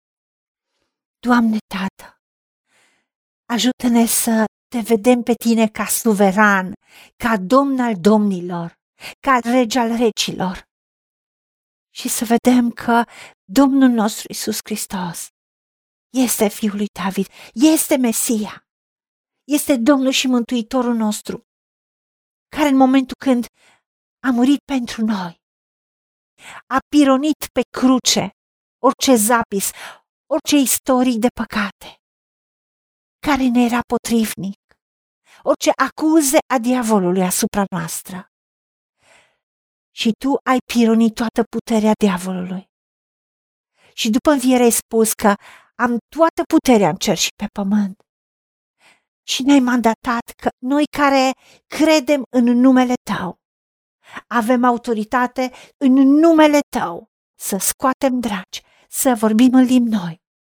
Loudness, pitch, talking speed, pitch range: -17 LUFS, 240 Hz, 110 wpm, 215-260 Hz